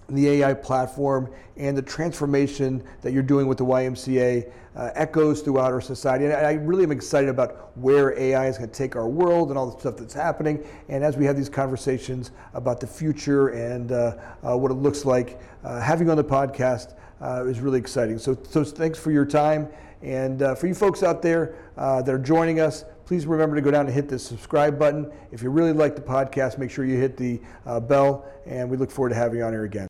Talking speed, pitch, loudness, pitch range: 230 wpm, 135 Hz, -23 LUFS, 125-150 Hz